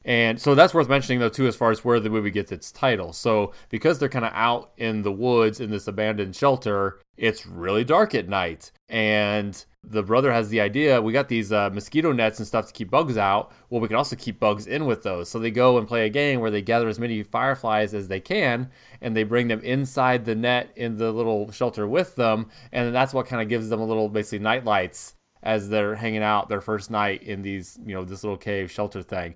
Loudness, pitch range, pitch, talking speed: -23 LUFS, 105-120 Hz, 110 Hz, 240 wpm